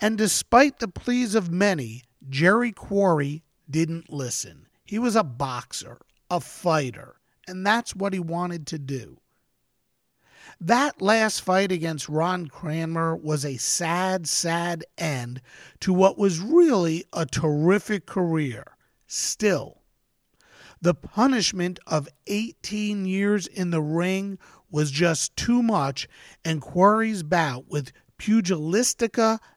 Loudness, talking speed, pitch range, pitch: -24 LUFS, 120 wpm, 155-205 Hz, 175 Hz